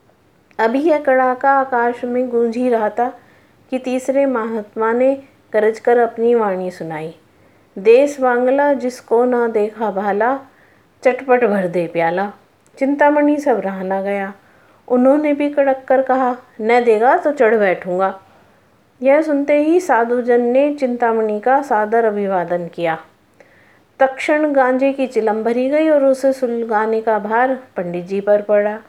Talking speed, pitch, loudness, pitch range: 140 wpm, 240 Hz, -16 LUFS, 210-265 Hz